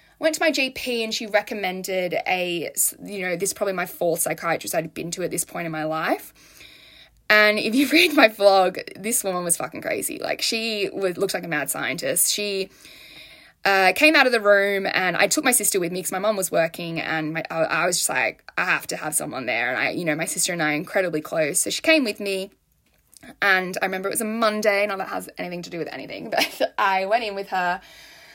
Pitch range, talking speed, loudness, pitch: 175-220 Hz, 240 wpm, -22 LUFS, 195 Hz